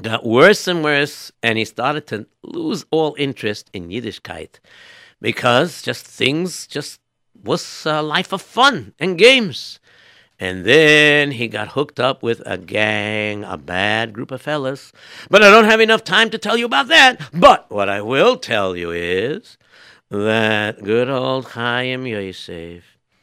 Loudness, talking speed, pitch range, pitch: -15 LUFS, 160 wpm, 105-160 Hz, 130 Hz